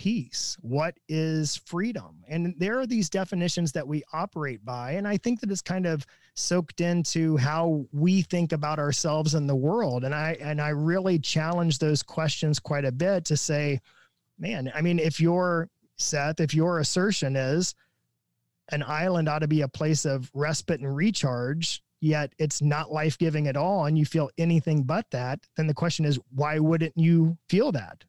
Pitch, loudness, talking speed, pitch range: 155 Hz, -26 LUFS, 180 wpm, 150-170 Hz